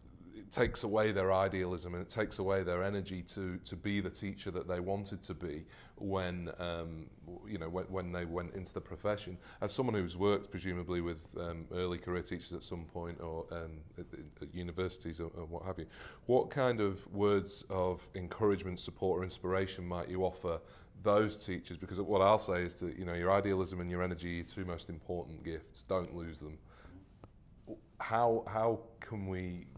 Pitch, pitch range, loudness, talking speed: 90 Hz, 85-100 Hz, -37 LUFS, 185 wpm